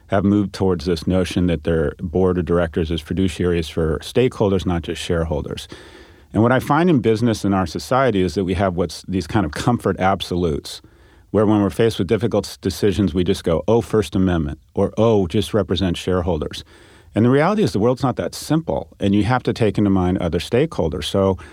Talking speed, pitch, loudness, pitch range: 205 wpm, 95 Hz, -19 LUFS, 90-105 Hz